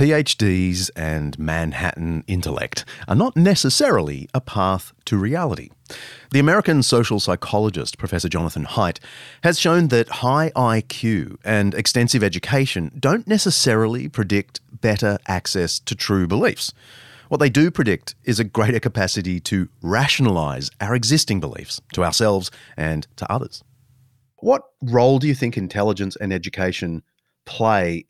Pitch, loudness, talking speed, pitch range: 110 Hz, -20 LUFS, 130 wpm, 90-130 Hz